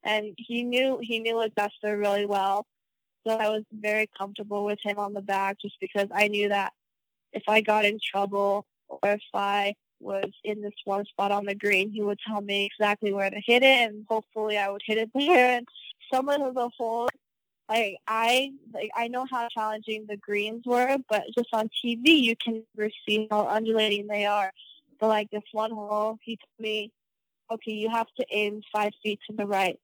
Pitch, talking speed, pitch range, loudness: 215 Hz, 210 wpm, 205-230 Hz, -27 LUFS